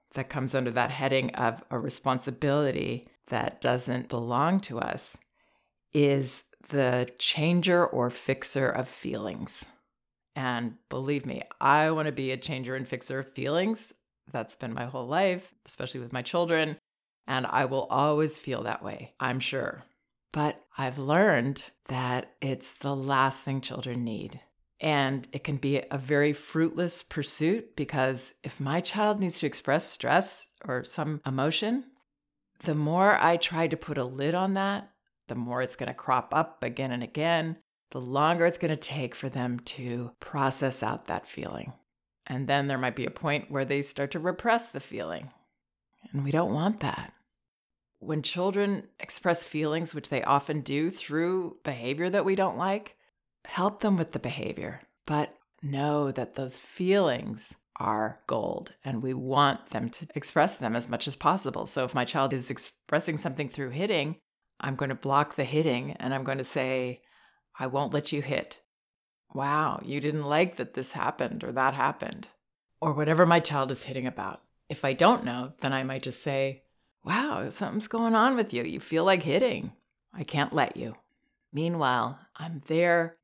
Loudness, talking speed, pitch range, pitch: -29 LUFS, 170 wpm, 130-165 Hz, 145 Hz